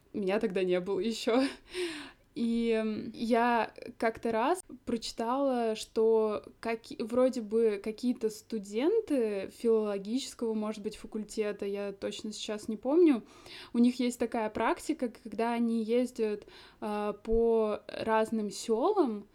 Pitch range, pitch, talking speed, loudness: 215-245 Hz, 230 Hz, 110 wpm, -31 LUFS